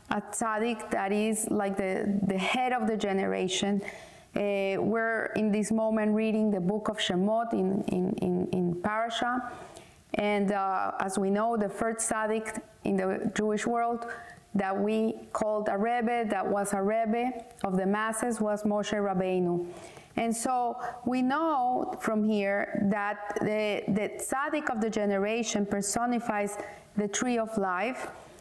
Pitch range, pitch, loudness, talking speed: 200-230 Hz, 215 Hz, -29 LUFS, 150 wpm